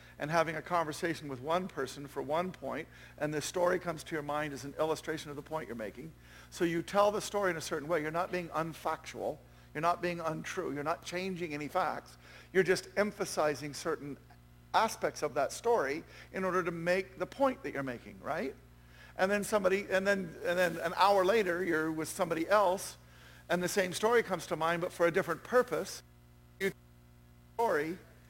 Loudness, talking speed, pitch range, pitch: -33 LUFS, 200 wpm, 135-180 Hz, 165 Hz